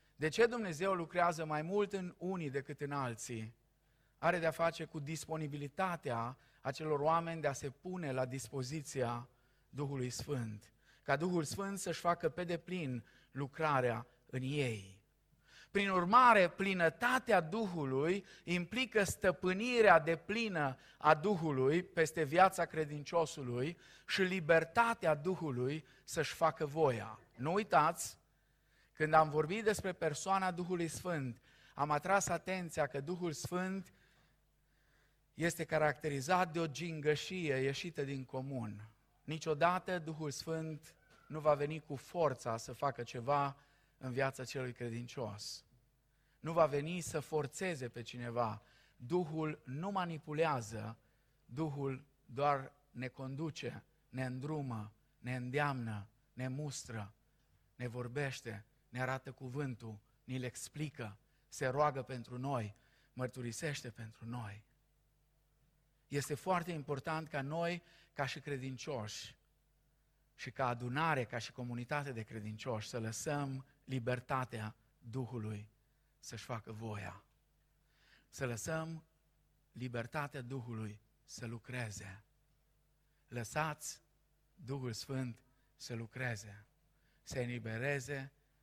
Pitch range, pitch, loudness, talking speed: 125-160 Hz, 145 Hz, -38 LUFS, 110 wpm